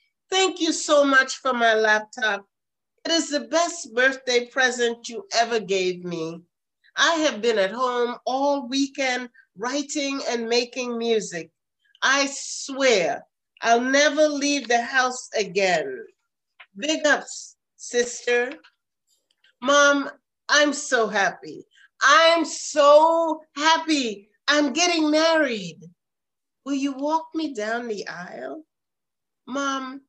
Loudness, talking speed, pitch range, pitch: -22 LUFS, 115 wpm, 235-305 Hz, 270 Hz